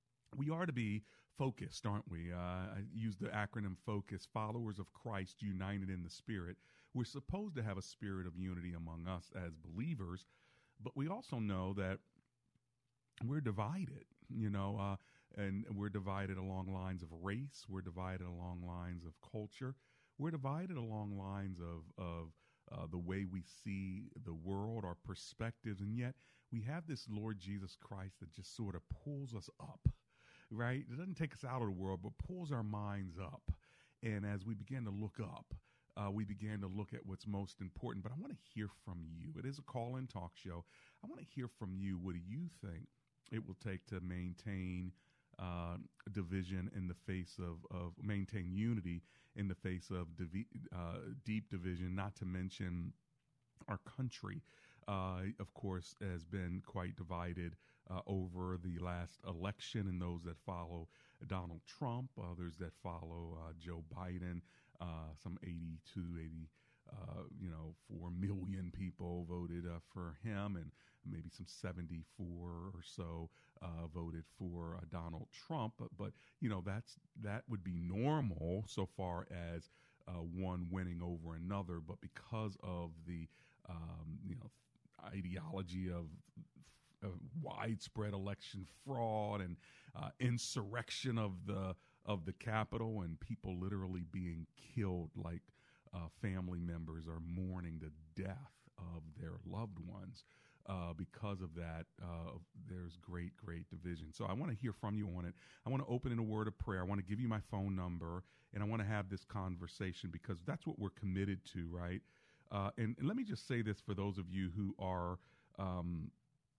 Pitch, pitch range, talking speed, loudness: 95 Hz, 90-110 Hz, 175 wpm, -46 LUFS